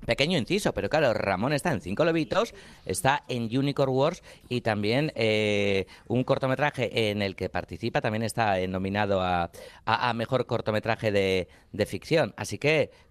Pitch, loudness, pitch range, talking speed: 110 Hz, -27 LUFS, 95-125 Hz, 165 wpm